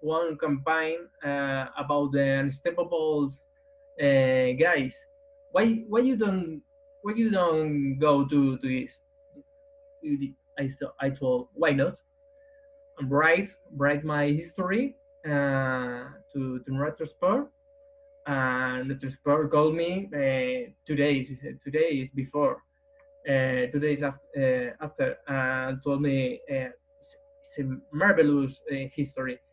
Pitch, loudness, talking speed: 150 Hz, -27 LUFS, 120 wpm